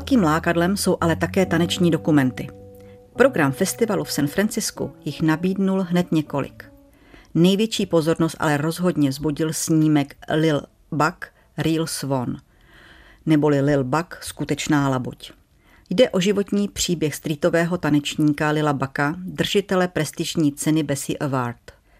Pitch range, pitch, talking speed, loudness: 145-175 Hz, 160 Hz, 120 wpm, -21 LUFS